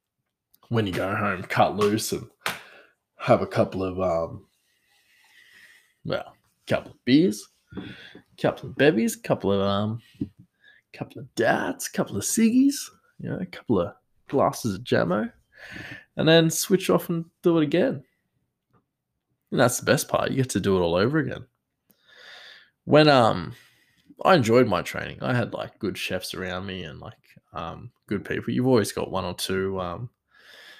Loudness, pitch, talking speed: -24 LUFS, 115 Hz, 165 wpm